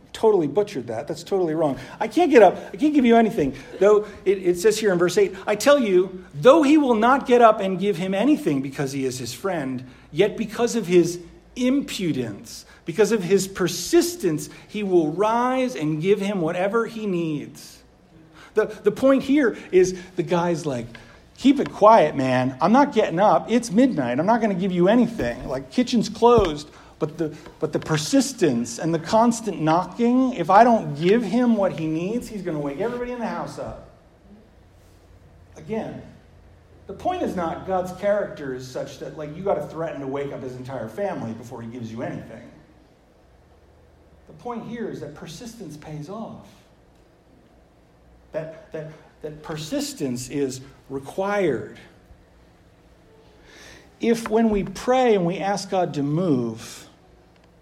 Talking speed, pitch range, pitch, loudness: 170 wpm, 145-220 Hz, 180 Hz, -21 LUFS